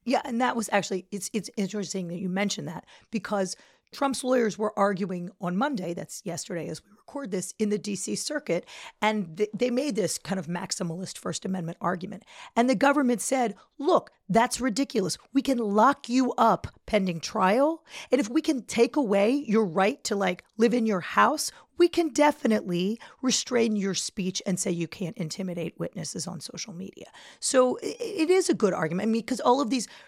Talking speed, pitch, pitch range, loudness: 190 wpm, 215 Hz, 190-260 Hz, -27 LUFS